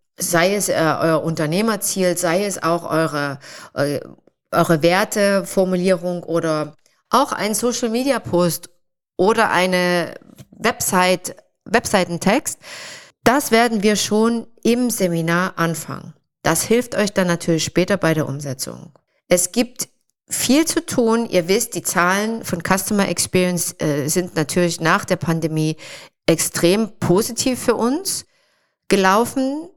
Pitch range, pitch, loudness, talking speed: 170-220 Hz, 180 Hz, -19 LUFS, 115 wpm